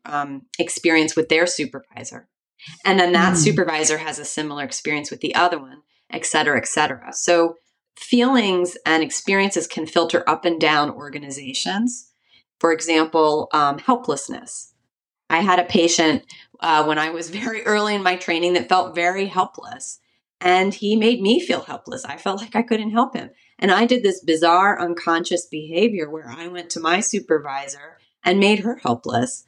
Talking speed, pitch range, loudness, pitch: 165 wpm, 155-195 Hz, -19 LUFS, 170 Hz